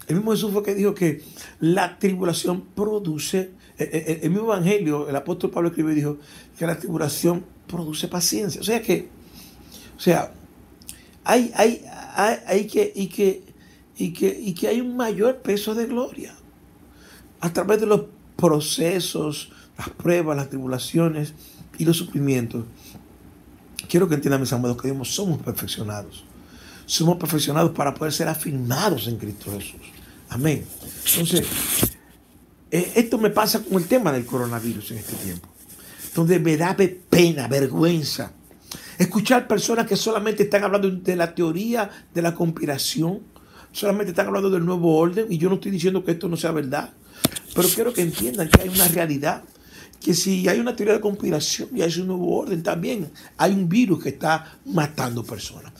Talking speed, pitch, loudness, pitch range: 150 wpm, 170 Hz, -22 LUFS, 150-195 Hz